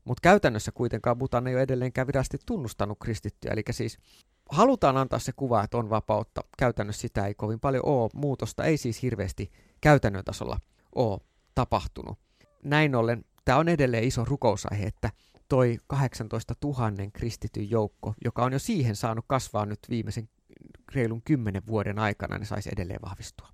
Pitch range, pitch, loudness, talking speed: 105-130 Hz, 115 Hz, -28 LUFS, 160 wpm